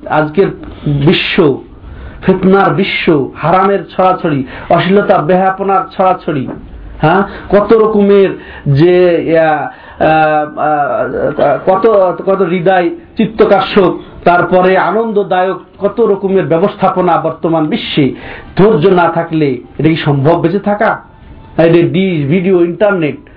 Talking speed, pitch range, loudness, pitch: 90 wpm, 165-195 Hz, -11 LUFS, 185 Hz